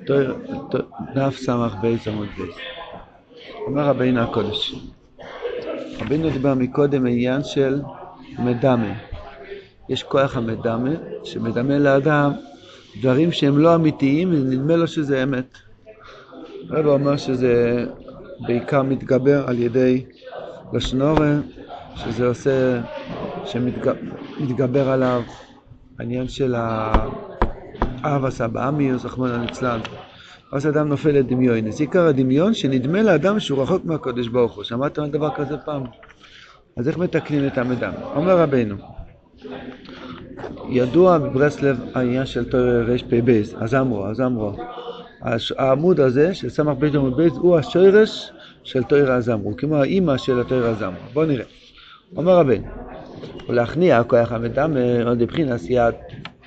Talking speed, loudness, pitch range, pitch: 125 wpm, -20 LUFS, 120-145 Hz, 130 Hz